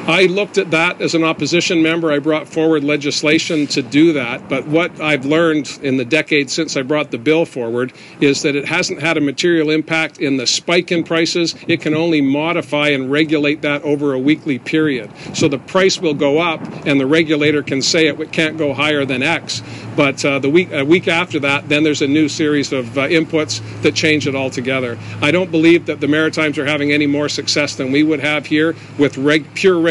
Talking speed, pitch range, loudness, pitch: 220 wpm, 145-160 Hz, -15 LUFS, 150 Hz